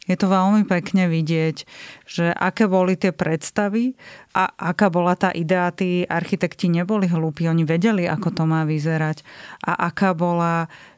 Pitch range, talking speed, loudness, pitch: 165-190 Hz, 155 wpm, -21 LUFS, 175 Hz